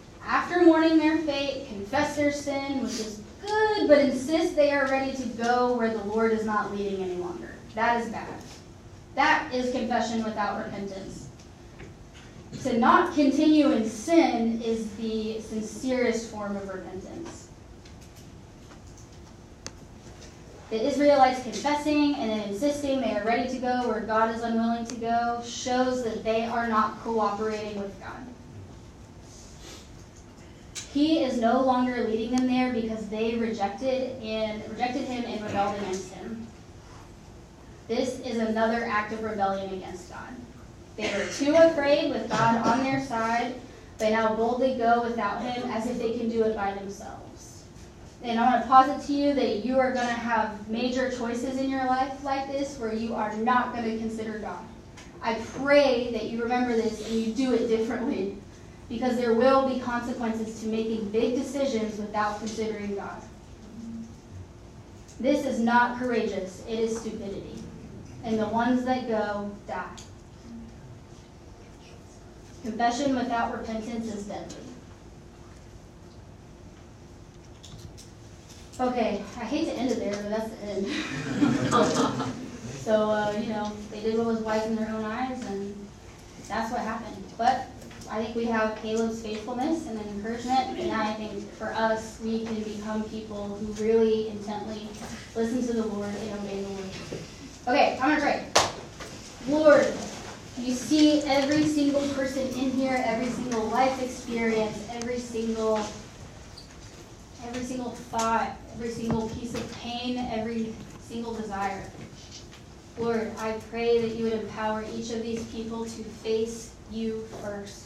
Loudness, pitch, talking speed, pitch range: -27 LUFS, 225 Hz, 145 wpm, 210-250 Hz